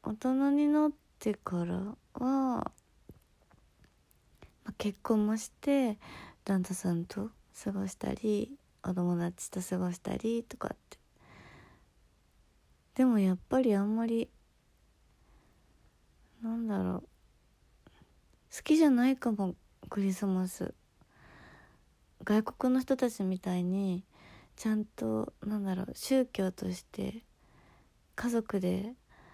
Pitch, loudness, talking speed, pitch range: 200 Hz, -33 LUFS, 195 characters per minute, 180-230 Hz